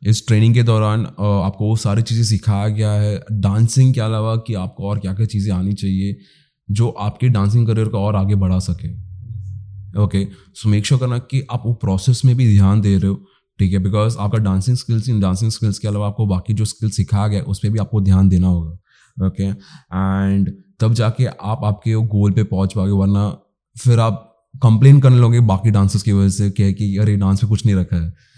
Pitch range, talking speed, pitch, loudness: 100-115 Hz, 215 wpm, 105 Hz, -17 LUFS